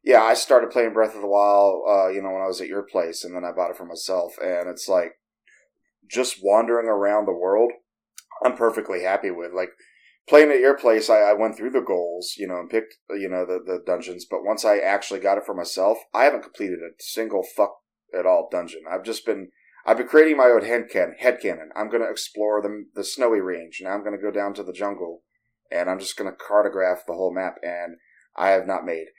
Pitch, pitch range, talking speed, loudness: 100 Hz, 90-110 Hz, 230 wpm, -22 LUFS